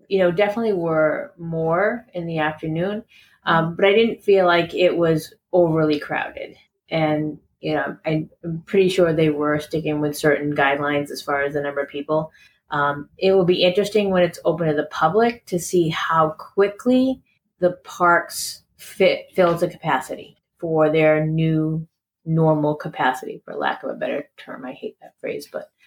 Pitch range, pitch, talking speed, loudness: 155-185 Hz, 165 Hz, 170 wpm, -20 LUFS